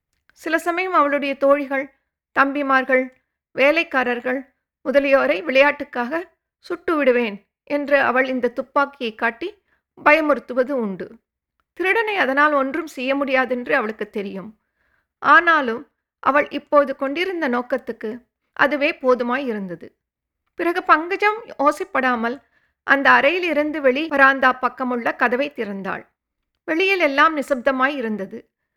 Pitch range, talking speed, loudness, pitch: 250-300 Hz, 100 wpm, -19 LUFS, 275 Hz